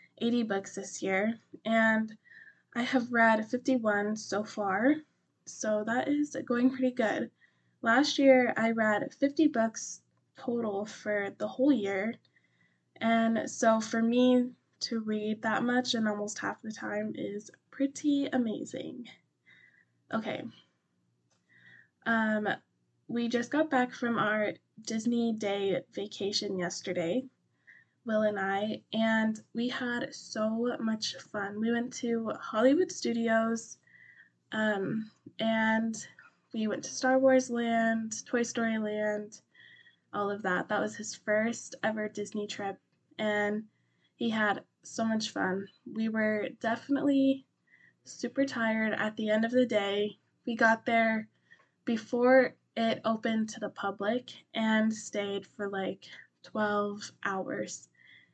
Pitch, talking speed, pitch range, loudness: 225 Hz, 125 wpm, 210-240 Hz, -31 LUFS